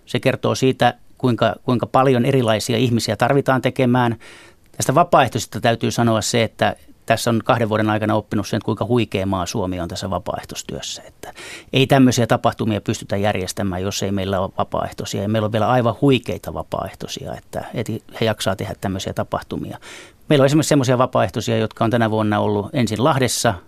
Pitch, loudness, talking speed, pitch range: 115 Hz, -19 LUFS, 165 wpm, 105-125 Hz